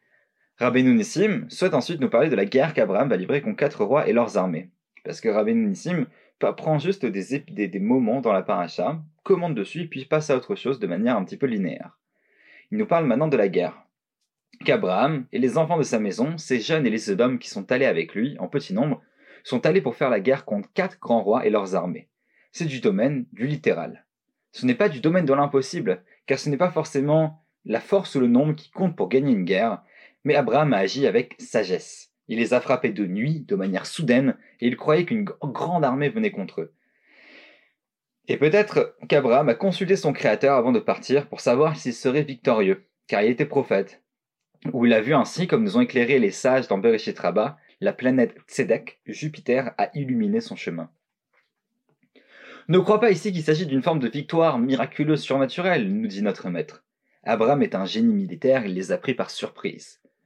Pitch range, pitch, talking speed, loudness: 135-200 Hz, 155 Hz, 205 wpm, -23 LUFS